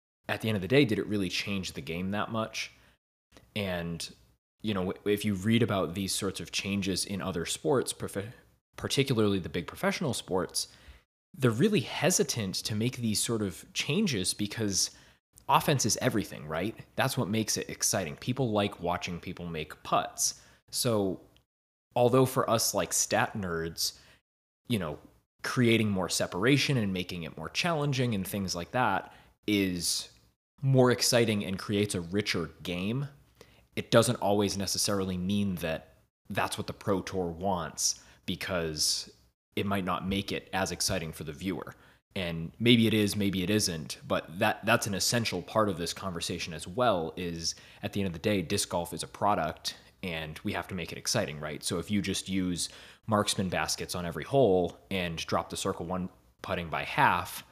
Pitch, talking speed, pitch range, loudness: 95 Hz, 175 wpm, 85-105 Hz, -30 LUFS